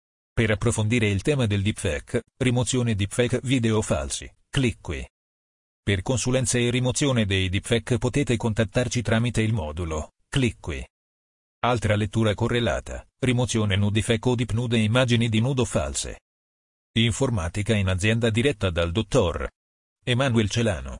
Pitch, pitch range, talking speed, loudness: 115 Hz, 100-120 Hz, 130 wpm, -24 LUFS